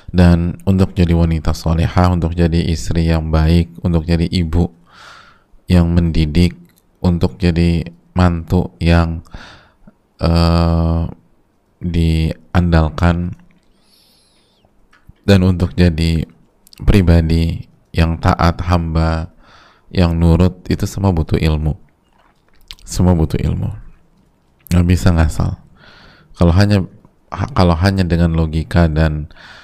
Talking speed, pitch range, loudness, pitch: 95 wpm, 80-90 Hz, -15 LUFS, 85 Hz